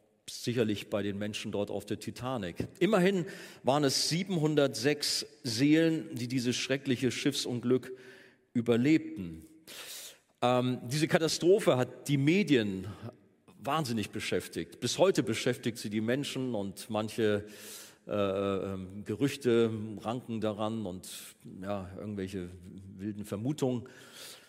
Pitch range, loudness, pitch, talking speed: 105-140 Hz, -31 LUFS, 120 Hz, 105 wpm